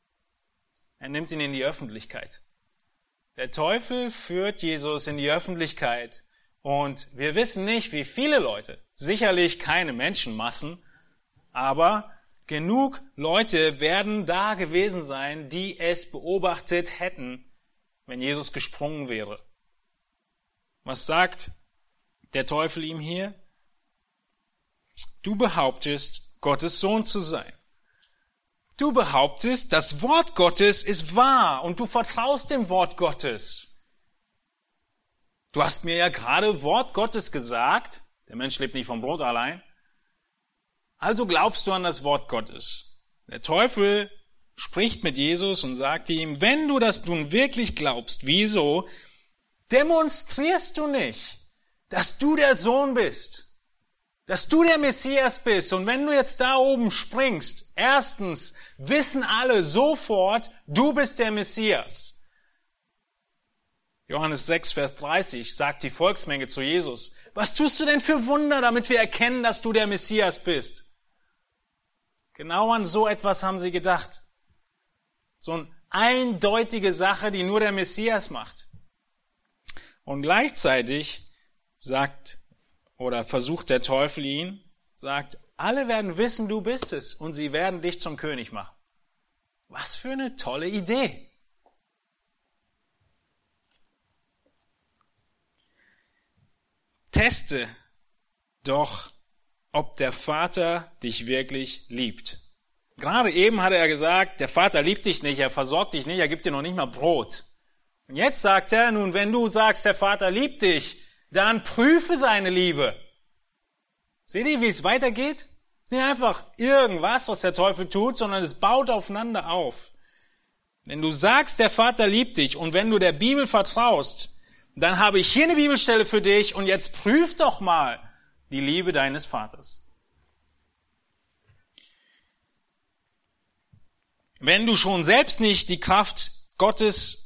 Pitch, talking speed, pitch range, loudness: 190 Hz, 130 wpm, 150-235 Hz, -23 LUFS